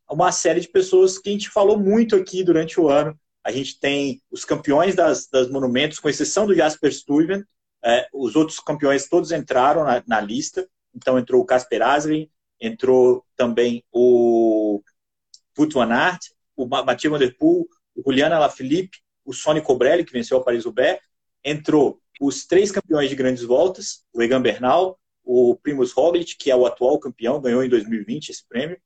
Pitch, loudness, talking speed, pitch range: 155 Hz, -19 LUFS, 170 wpm, 130-190 Hz